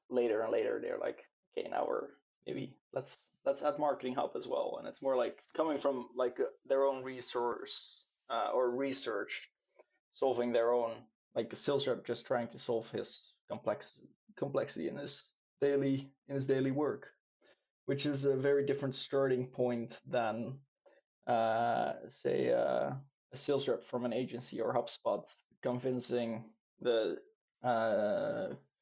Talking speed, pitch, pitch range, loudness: 150 wpm, 135 Hz, 125-140 Hz, -35 LUFS